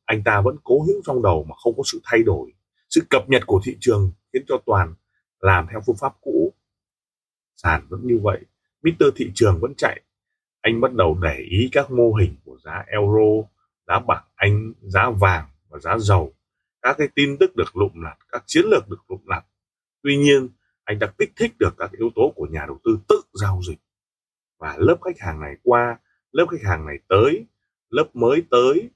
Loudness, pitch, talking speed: -20 LUFS, 140 Hz, 205 wpm